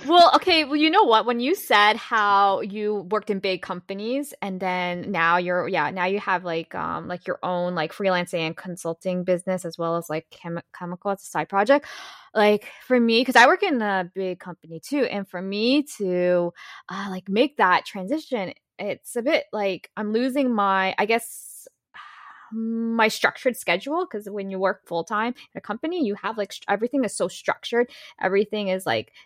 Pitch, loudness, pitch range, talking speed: 200 Hz, -23 LUFS, 180-245 Hz, 195 wpm